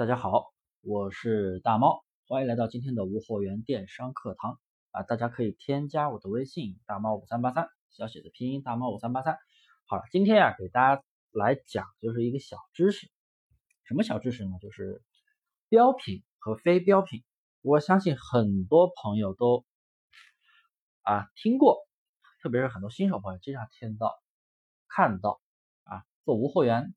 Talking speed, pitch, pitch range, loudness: 250 characters per minute, 125 Hz, 110-170 Hz, -28 LUFS